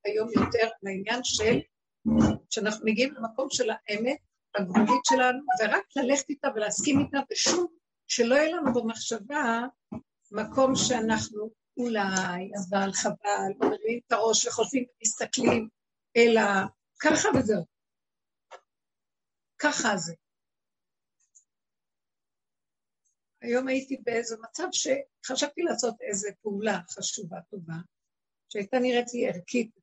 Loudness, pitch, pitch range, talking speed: -27 LUFS, 230 Hz, 210-260 Hz, 105 wpm